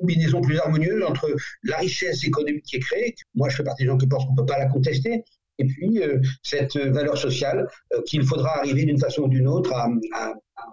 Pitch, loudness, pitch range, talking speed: 140 Hz, -23 LUFS, 135-155 Hz, 235 wpm